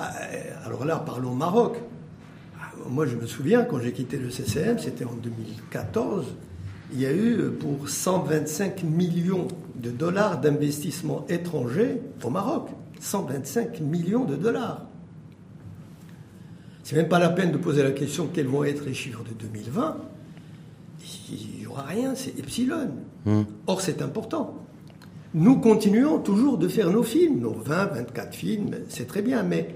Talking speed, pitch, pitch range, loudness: 145 wpm, 155 Hz, 130-190 Hz, -26 LUFS